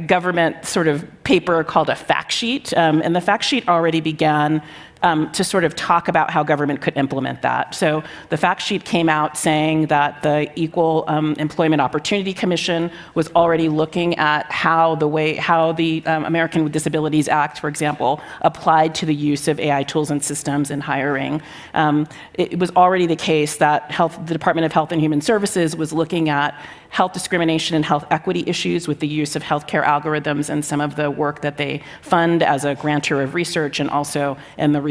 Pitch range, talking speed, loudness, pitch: 150-170 Hz, 200 wpm, -19 LUFS, 155 Hz